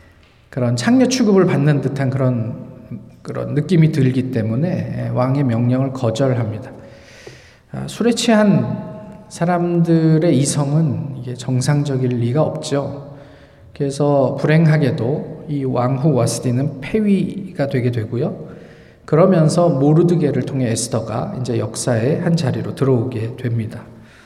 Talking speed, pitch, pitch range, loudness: 270 characters per minute, 140 Hz, 125-160 Hz, -17 LUFS